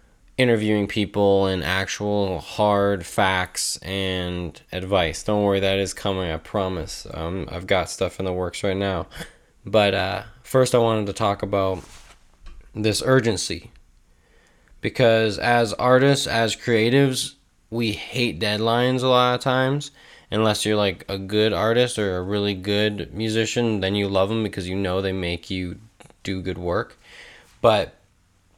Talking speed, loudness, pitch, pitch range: 150 wpm, -22 LUFS, 100 Hz, 95-115 Hz